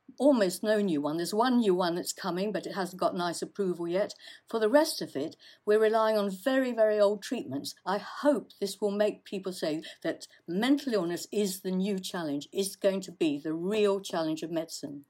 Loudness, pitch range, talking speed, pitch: -30 LUFS, 175-220 Hz, 205 wpm, 200 Hz